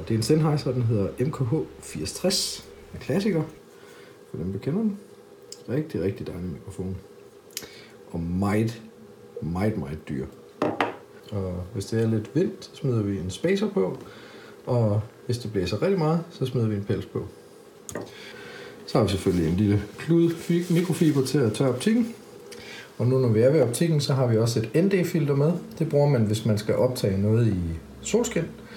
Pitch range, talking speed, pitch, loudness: 105-170 Hz, 175 wpm, 125 Hz, -25 LUFS